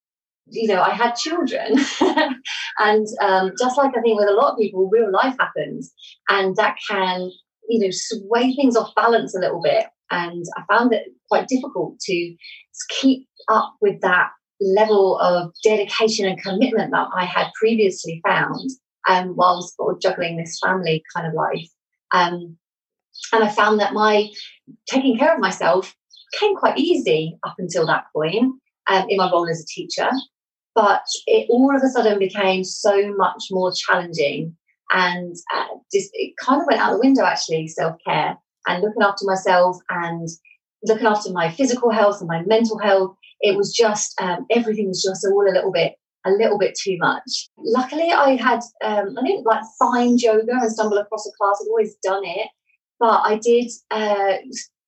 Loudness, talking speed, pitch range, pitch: -19 LUFS, 175 wpm, 185-250 Hz, 210 Hz